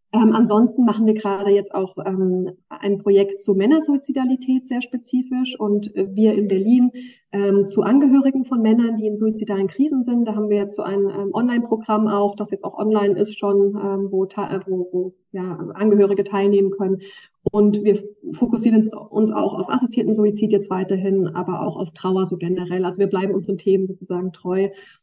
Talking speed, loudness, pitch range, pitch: 180 wpm, -20 LUFS, 195-220 Hz, 205 Hz